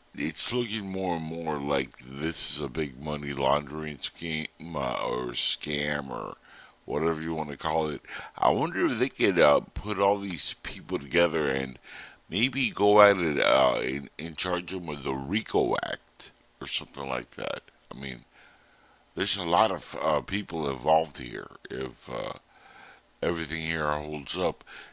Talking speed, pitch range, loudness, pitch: 160 wpm, 70-85 Hz, -28 LUFS, 80 Hz